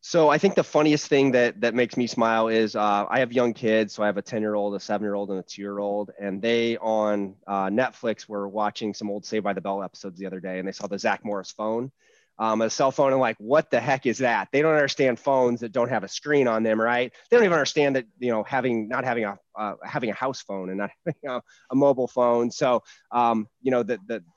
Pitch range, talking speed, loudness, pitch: 105-130 Hz, 270 wpm, -24 LUFS, 115 Hz